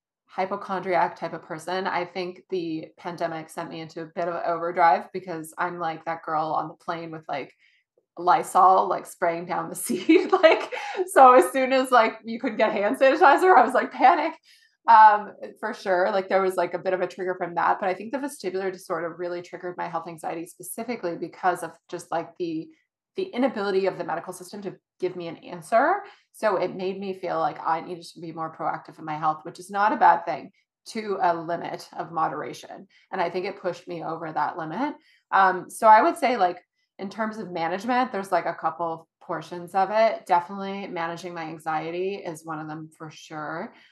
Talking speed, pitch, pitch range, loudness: 205 wpm, 180 Hz, 170-215 Hz, -24 LUFS